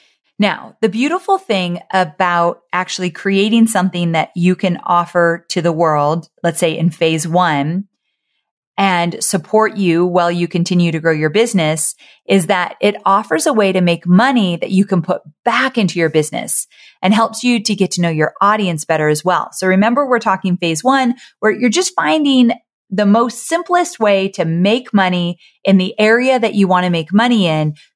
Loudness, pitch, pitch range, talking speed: -15 LUFS, 185 Hz, 170-220 Hz, 180 wpm